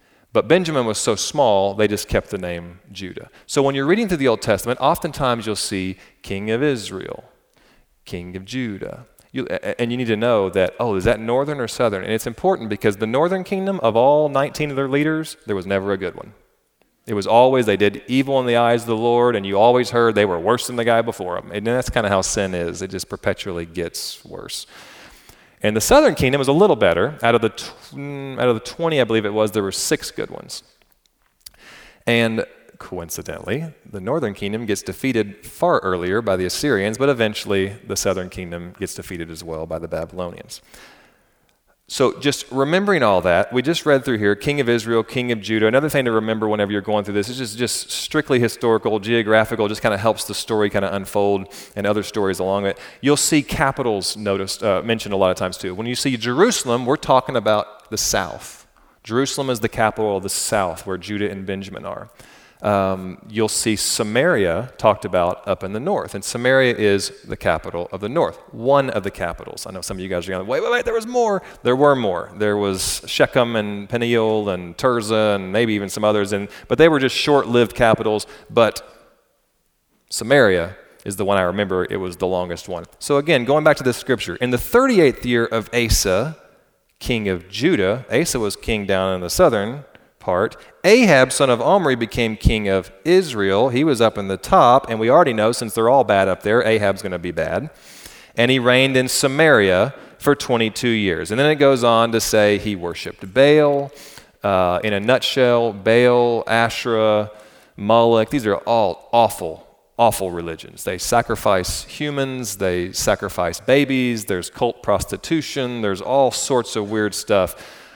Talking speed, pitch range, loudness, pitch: 200 wpm, 100-130 Hz, -19 LUFS, 110 Hz